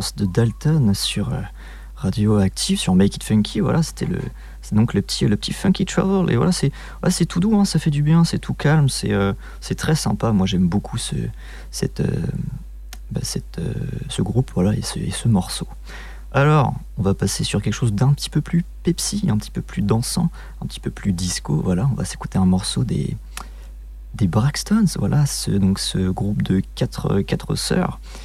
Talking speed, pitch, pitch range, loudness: 210 wpm, 115 Hz, 95-160 Hz, -20 LUFS